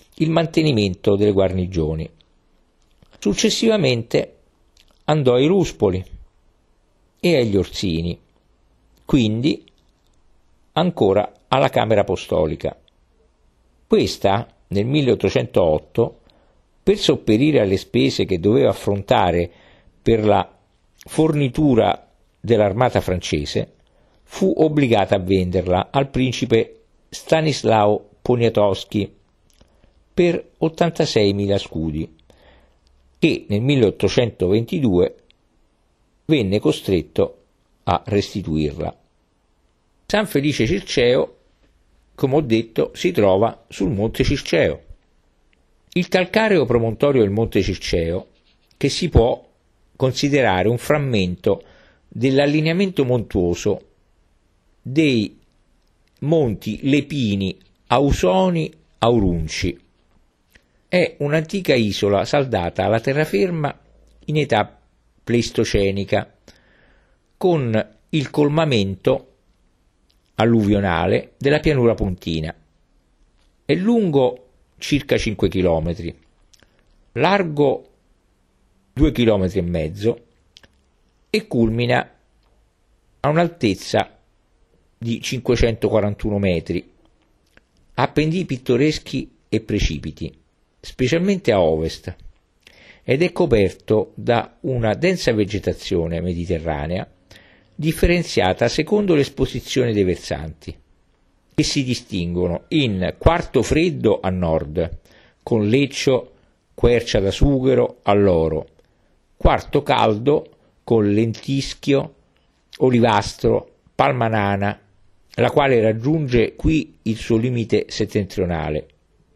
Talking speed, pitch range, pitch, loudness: 80 wpm, 90-140 Hz, 105 Hz, -19 LUFS